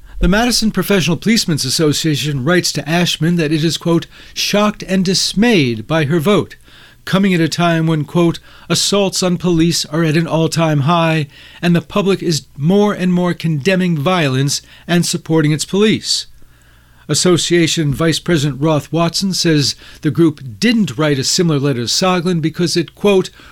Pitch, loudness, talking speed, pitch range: 165 Hz, -14 LUFS, 160 wpm, 155-180 Hz